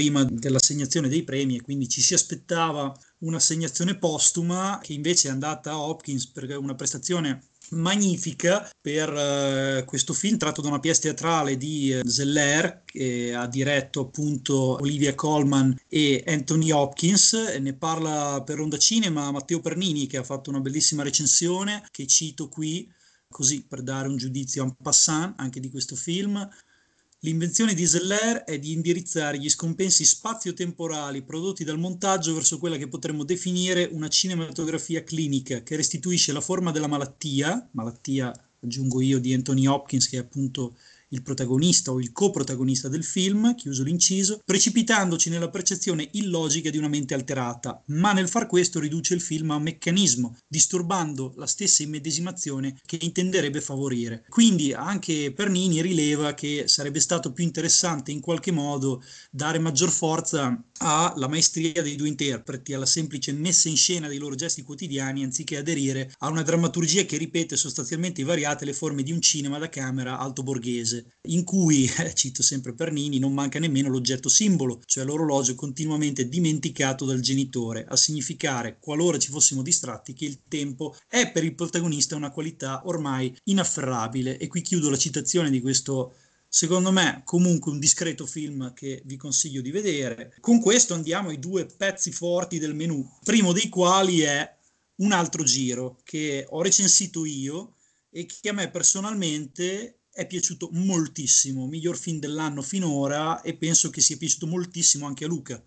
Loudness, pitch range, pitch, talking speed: -24 LUFS, 135-170 Hz, 155 Hz, 160 wpm